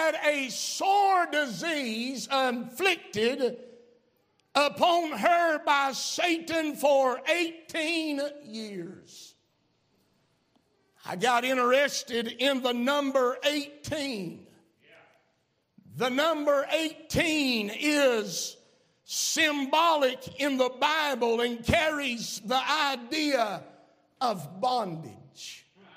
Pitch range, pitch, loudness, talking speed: 245-310 Hz, 275 Hz, -27 LUFS, 75 wpm